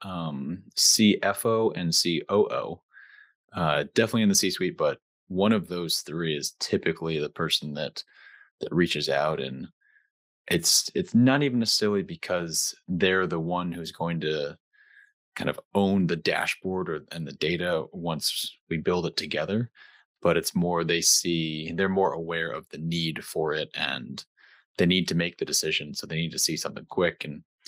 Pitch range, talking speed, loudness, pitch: 85-105 Hz, 180 wpm, -26 LUFS, 90 Hz